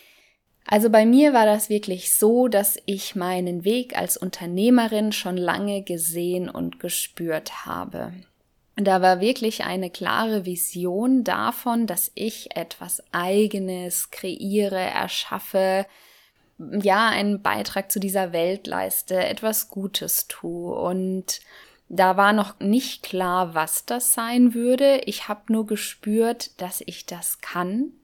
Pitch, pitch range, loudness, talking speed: 200 Hz, 180-220 Hz, -22 LUFS, 130 wpm